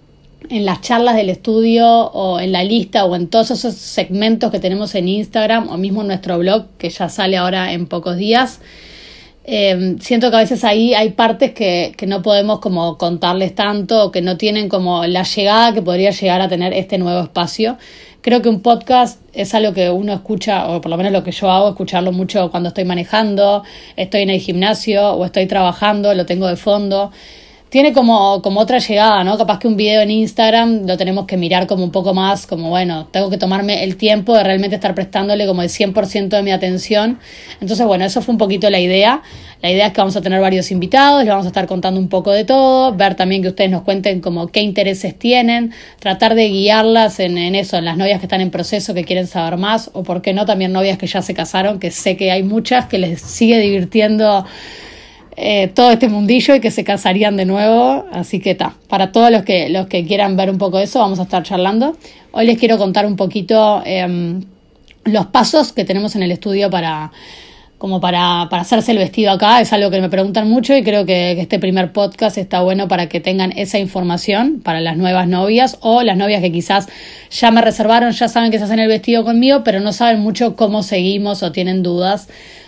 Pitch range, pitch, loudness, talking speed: 185-220 Hz, 200 Hz, -14 LUFS, 220 wpm